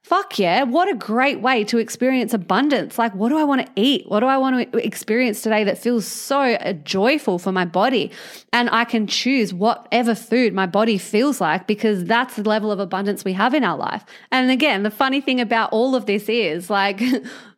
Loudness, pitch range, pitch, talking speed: -19 LUFS, 210-255 Hz, 230 Hz, 210 wpm